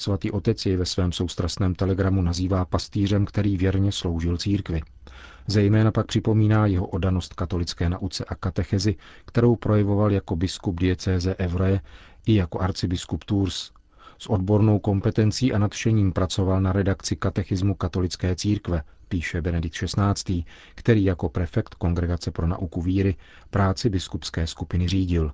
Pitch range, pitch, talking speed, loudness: 90-100 Hz, 95 Hz, 135 wpm, -24 LUFS